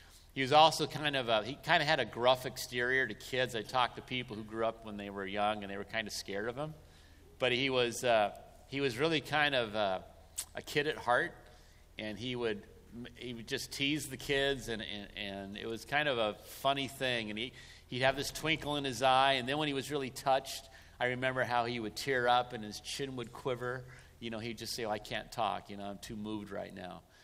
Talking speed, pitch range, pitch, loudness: 245 wpm, 105-135 Hz, 125 Hz, -34 LUFS